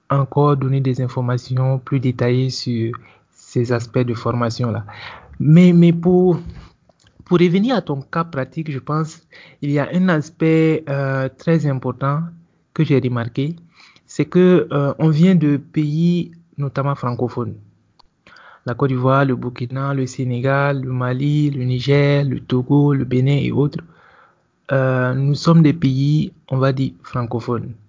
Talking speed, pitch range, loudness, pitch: 150 wpm, 125-160 Hz, -18 LUFS, 140 Hz